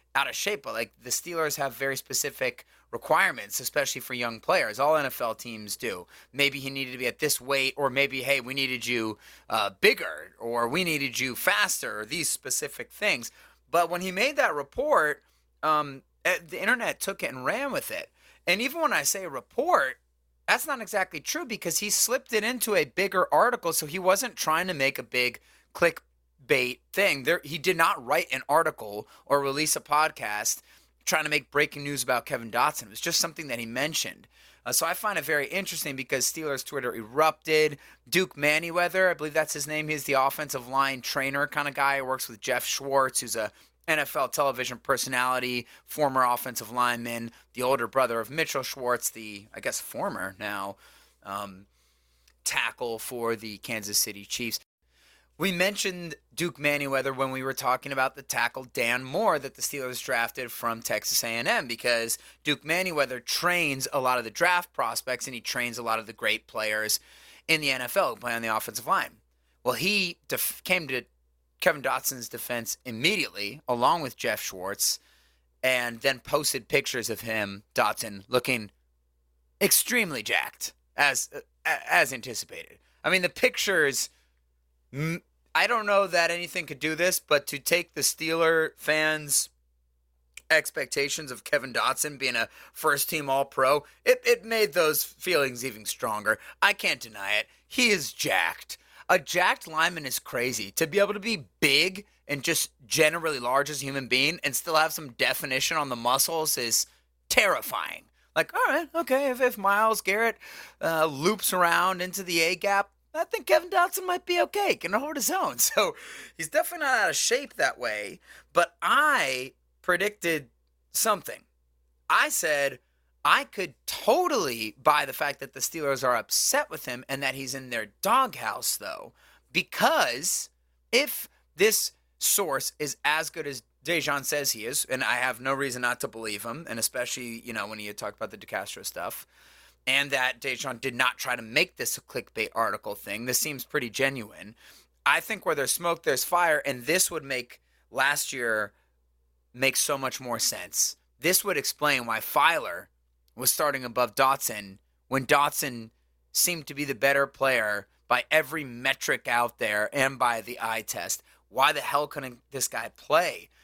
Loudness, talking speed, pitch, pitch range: -26 LUFS, 175 wpm, 135 Hz, 115-160 Hz